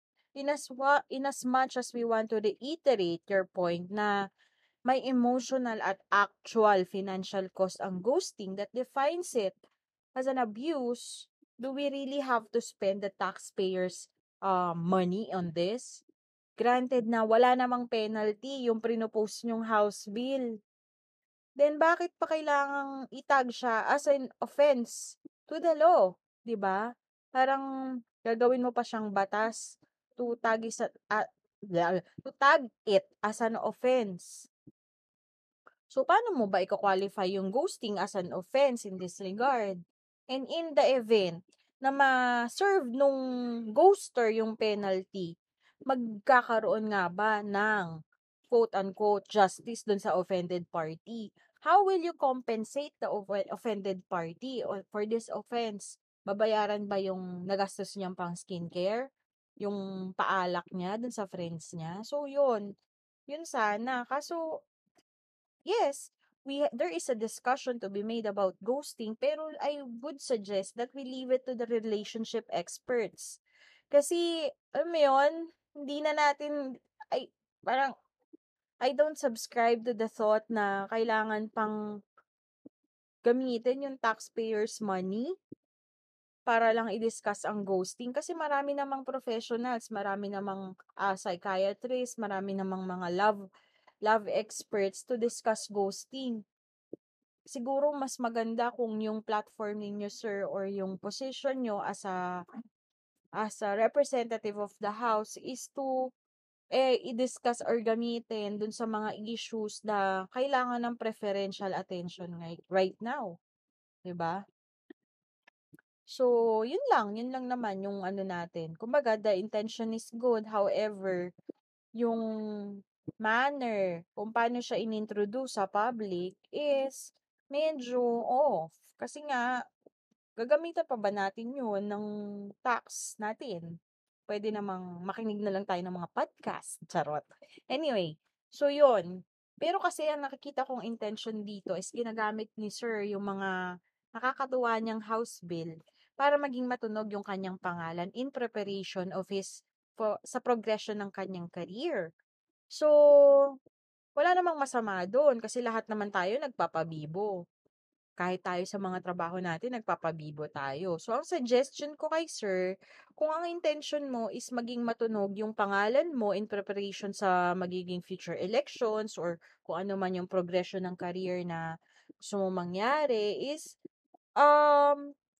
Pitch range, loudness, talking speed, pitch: 195-260 Hz, -32 LUFS, 130 wpm, 225 Hz